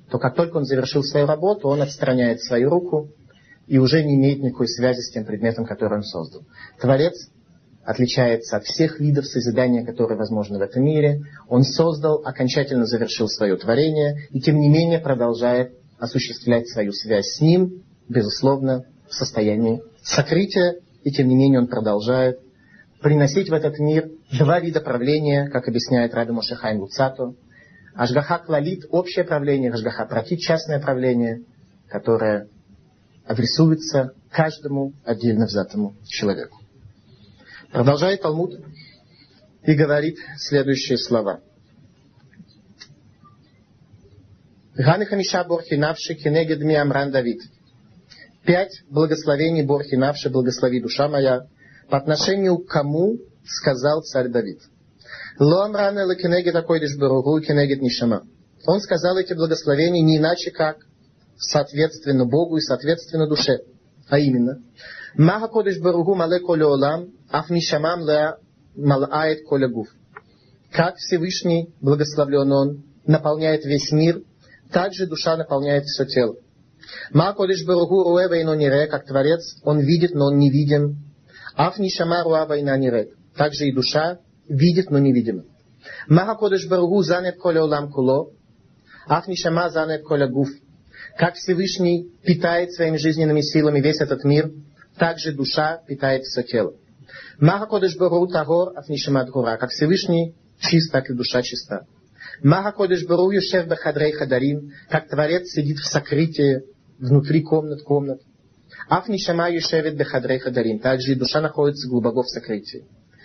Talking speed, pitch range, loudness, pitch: 115 wpm, 130-165 Hz, -20 LUFS, 145 Hz